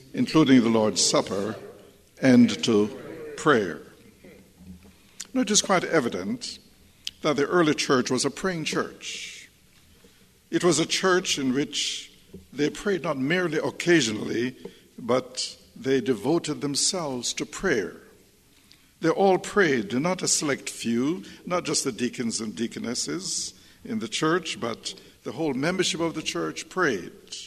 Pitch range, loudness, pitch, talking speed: 130-180 Hz, -25 LUFS, 155 Hz, 135 wpm